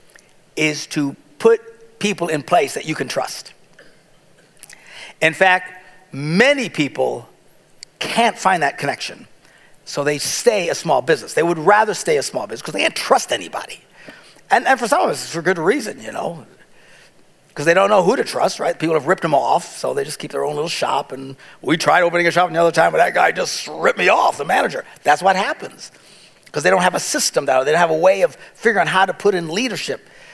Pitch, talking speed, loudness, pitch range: 180 Hz, 220 wpm, -17 LUFS, 155-220 Hz